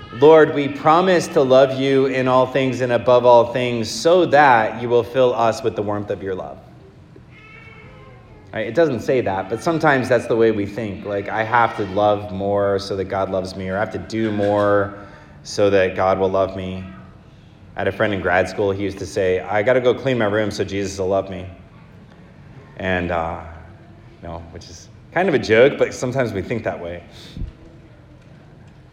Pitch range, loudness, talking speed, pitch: 95-130 Hz, -18 LUFS, 205 wpm, 110 Hz